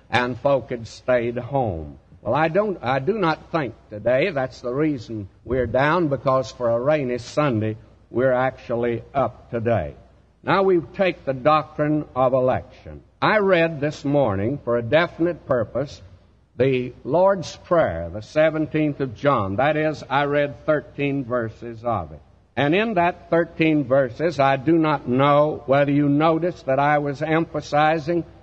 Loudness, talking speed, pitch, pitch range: -21 LUFS, 155 wpm, 140 Hz, 120-155 Hz